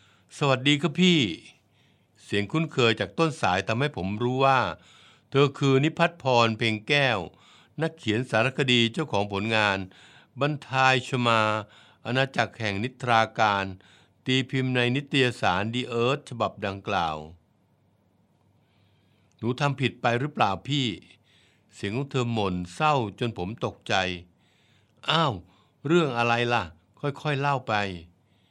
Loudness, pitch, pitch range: -25 LUFS, 115 Hz, 100-135 Hz